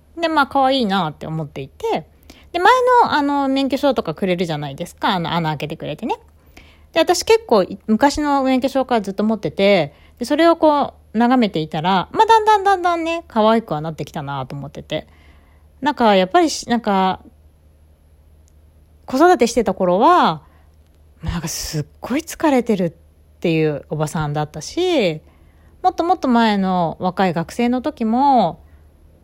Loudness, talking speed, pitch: -18 LUFS, 325 characters per minute, 195 Hz